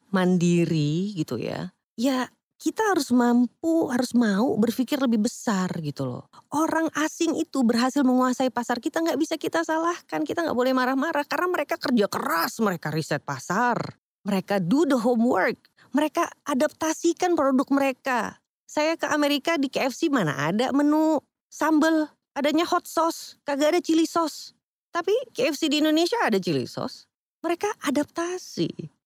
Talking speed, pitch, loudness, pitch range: 140 wpm, 280 Hz, -24 LUFS, 230-320 Hz